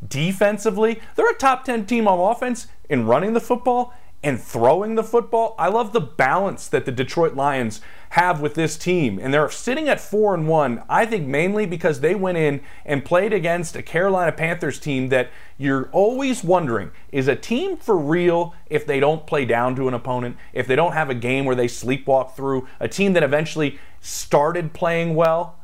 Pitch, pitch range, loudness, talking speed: 165 Hz, 135-210 Hz, -20 LUFS, 195 wpm